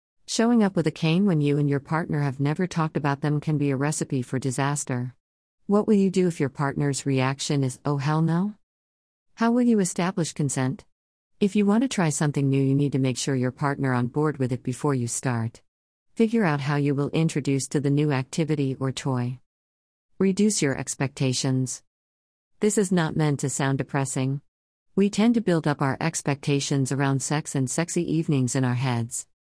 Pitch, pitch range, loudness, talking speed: 145 Hz, 130-165 Hz, -24 LUFS, 195 wpm